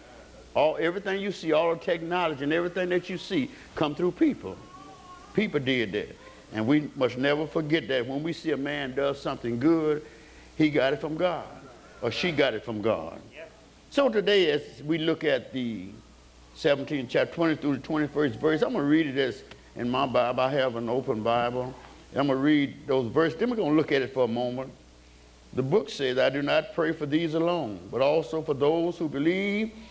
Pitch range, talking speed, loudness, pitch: 130-165 Hz, 200 wpm, -27 LUFS, 150 Hz